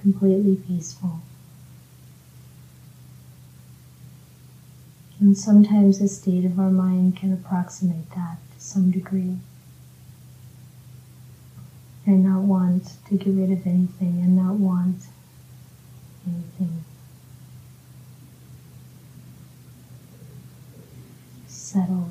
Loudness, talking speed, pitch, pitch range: -21 LUFS, 75 wpm, 135 Hz, 130-185 Hz